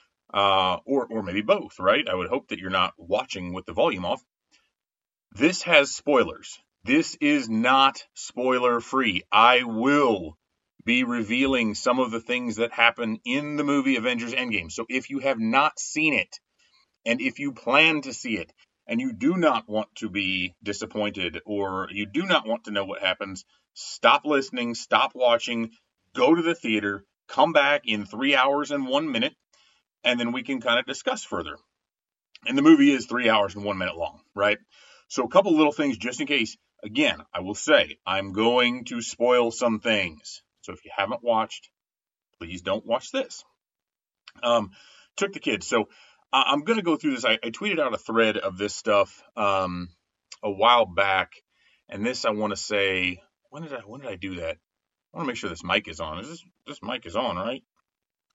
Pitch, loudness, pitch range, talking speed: 120 Hz, -24 LUFS, 105-150 Hz, 190 wpm